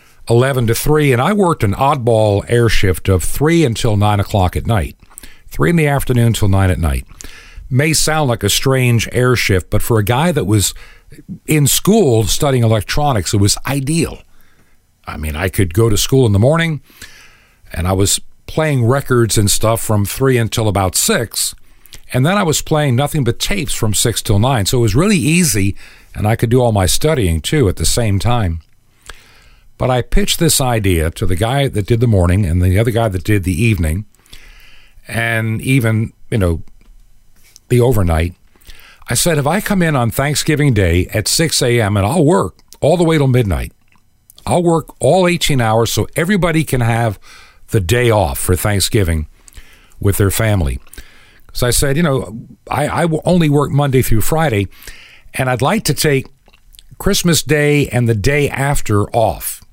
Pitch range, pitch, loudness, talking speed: 100-140 Hz, 115 Hz, -14 LUFS, 185 wpm